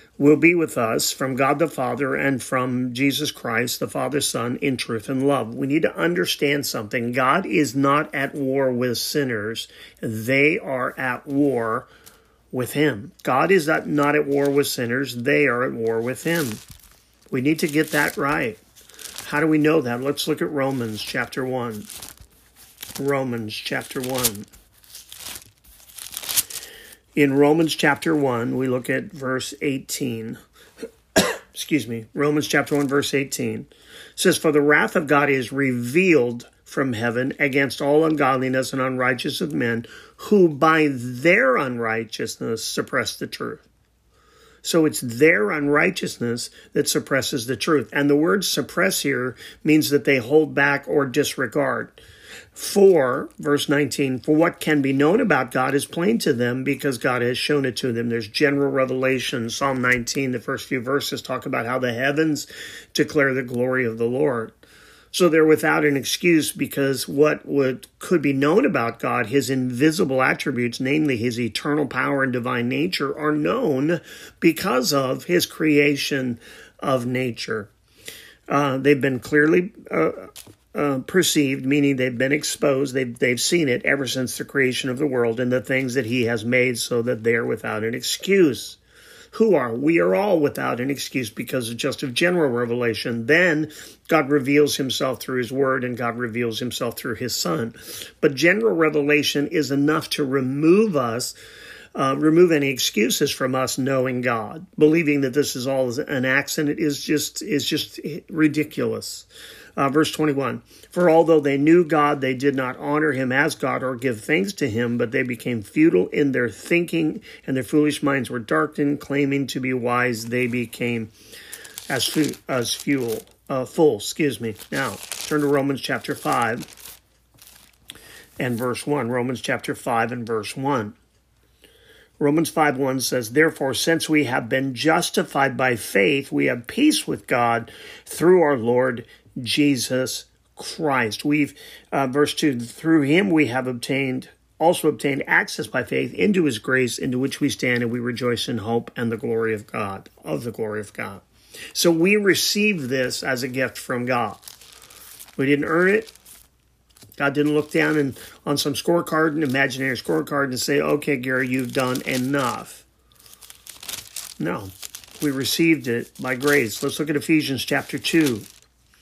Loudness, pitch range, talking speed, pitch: -21 LUFS, 125-150 Hz, 160 wpm, 140 Hz